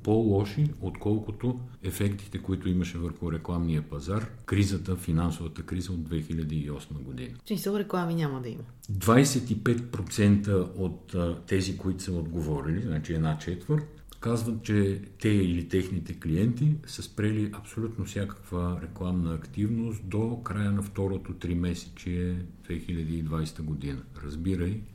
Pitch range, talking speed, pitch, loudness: 85-110 Hz, 120 wpm, 95 Hz, -30 LUFS